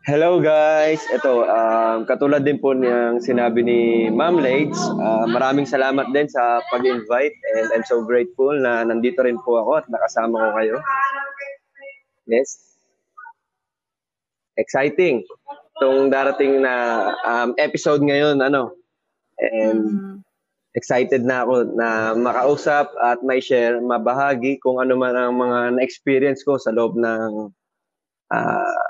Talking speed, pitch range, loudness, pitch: 125 wpm, 120-150 Hz, -19 LUFS, 130 Hz